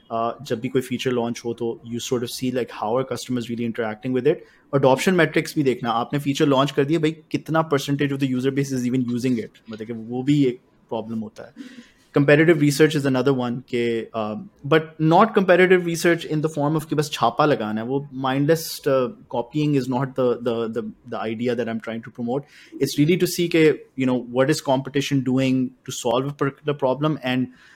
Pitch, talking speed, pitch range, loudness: 130 Hz, 205 wpm, 120-150 Hz, -22 LUFS